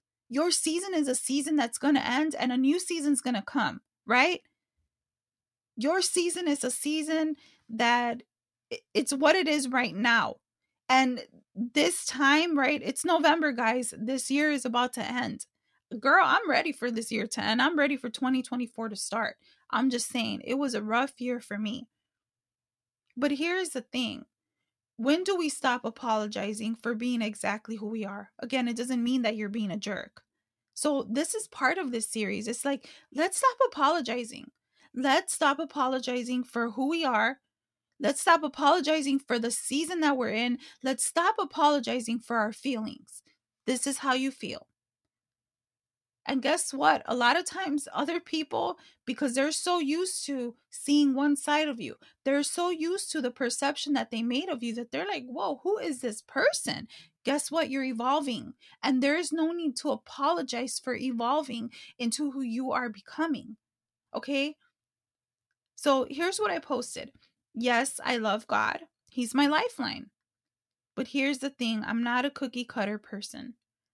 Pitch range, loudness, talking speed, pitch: 235-300 Hz, -28 LUFS, 170 wpm, 260 Hz